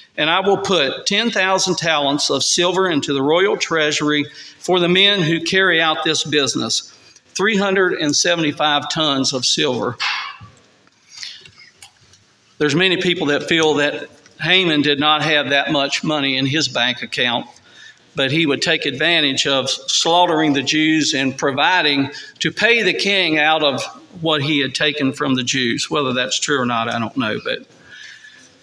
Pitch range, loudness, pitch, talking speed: 140-175 Hz, -16 LUFS, 155 Hz, 155 wpm